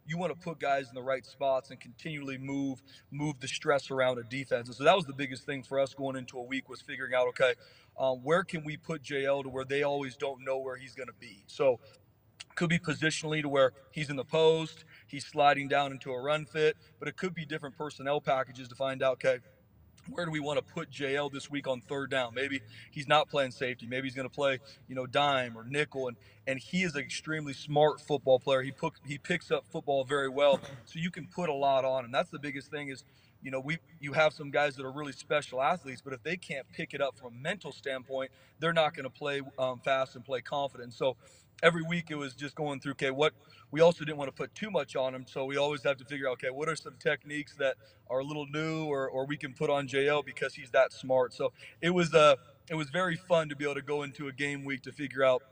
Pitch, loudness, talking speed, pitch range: 140 Hz, -32 LUFS, 260 wpm, 130-150 Hz